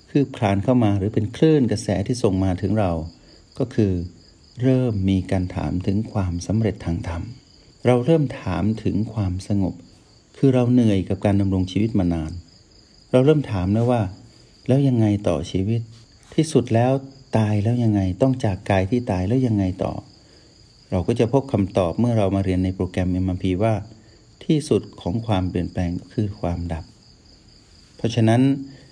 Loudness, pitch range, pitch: -21 LUFS, 95-120 Hz, 105 Hz